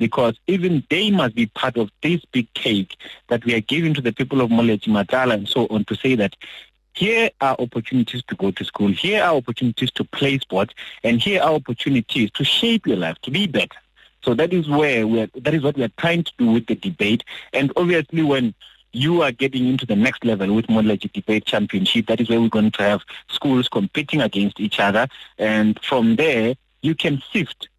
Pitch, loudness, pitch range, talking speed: 125 Hz, -20 LUFS, 110-150 Hz, 215 wpm